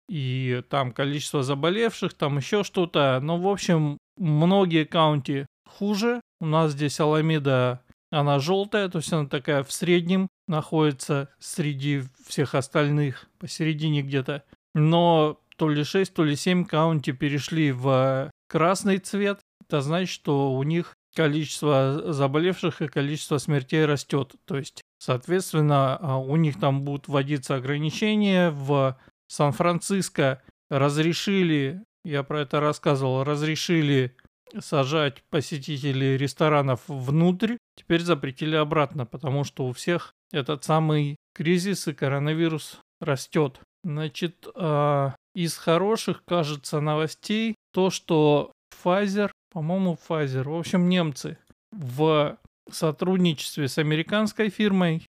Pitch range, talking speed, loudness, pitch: 140-175 Hz, 115 wpm, -25 LUFS, 155 Hz